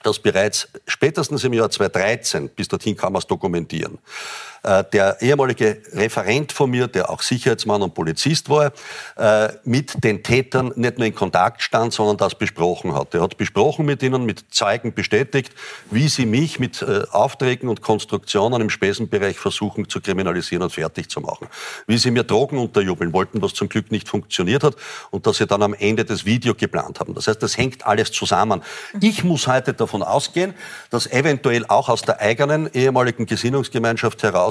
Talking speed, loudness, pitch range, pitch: 175 wpm, -19 LUFS, 110-140 Hz, 120 Hz